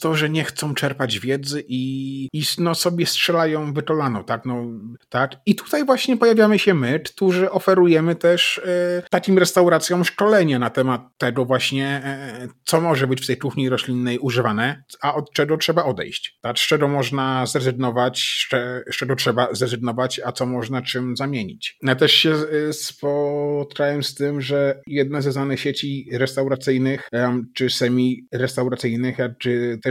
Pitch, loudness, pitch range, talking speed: 135 Hz, -20 LUFS, 125-155 Hz, 155 wpm